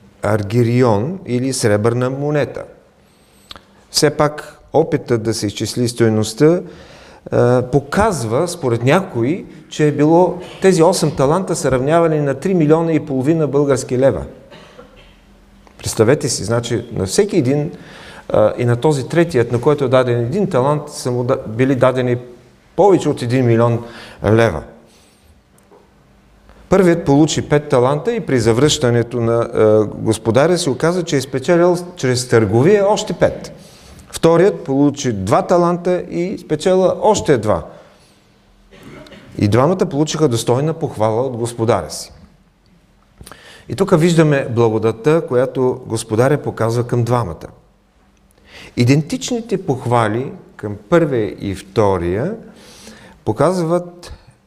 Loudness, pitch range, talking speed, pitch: -16 LUFS, 120-165 Hz, 115 wpm, 135 Hz